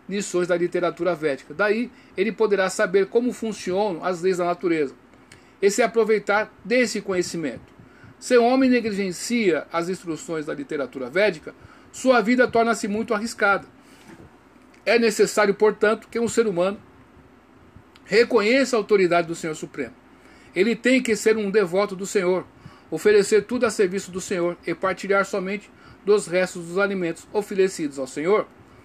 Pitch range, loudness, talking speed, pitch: 180-225 Hz, -22 LUFS, 145 wpm, 205 Hz